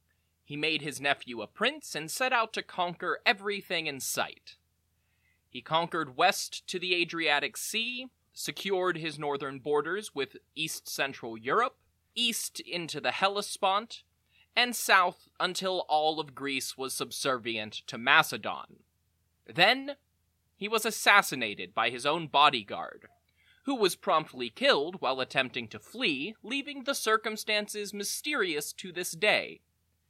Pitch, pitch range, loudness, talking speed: 165 Hz, 130-210 Hz, -29 LUFS, 130 wpm